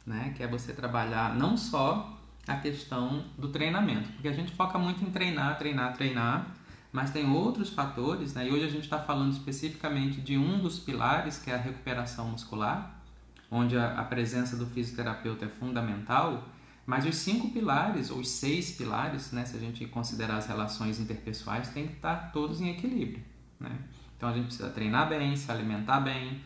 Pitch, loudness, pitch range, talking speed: 130 Hz, -32 LUFS, 120-150 Hz, 185 wpm